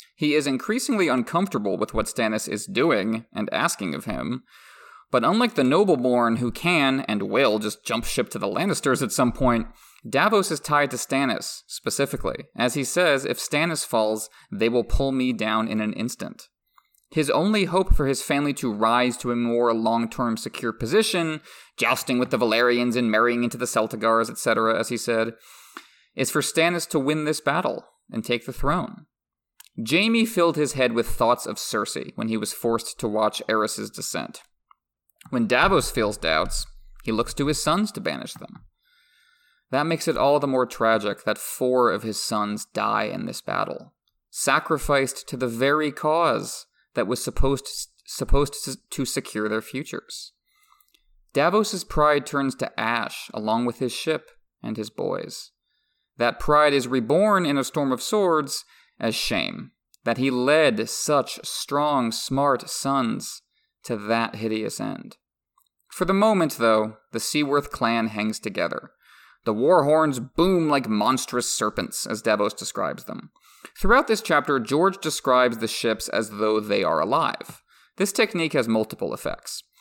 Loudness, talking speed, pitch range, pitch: -23 LUFS, 165 wpm, 115-155 Hz, 135 Hz